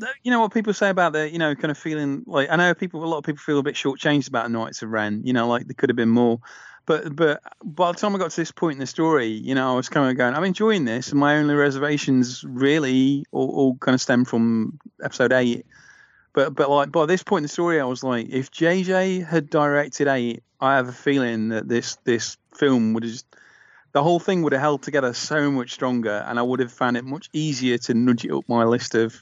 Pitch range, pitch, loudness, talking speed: 125-160 Hz, 140 Hz, -22 LUFS, 260 wpm